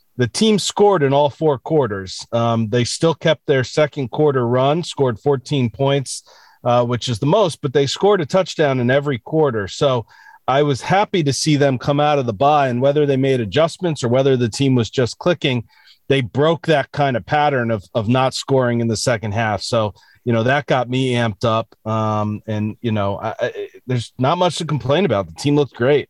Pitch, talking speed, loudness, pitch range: 135 Hz, 215 wpm, -18 LUFS, 120-150 Hz